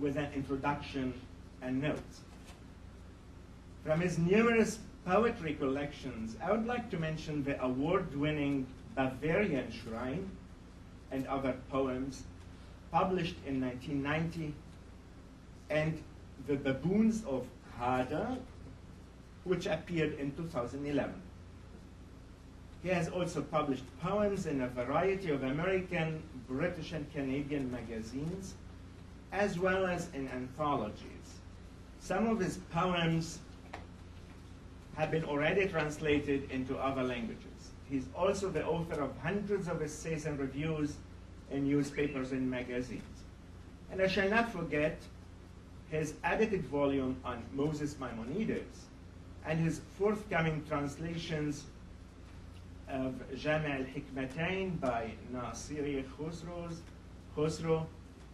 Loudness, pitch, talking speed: -35 LUFS, 135 Hz, 105 wpm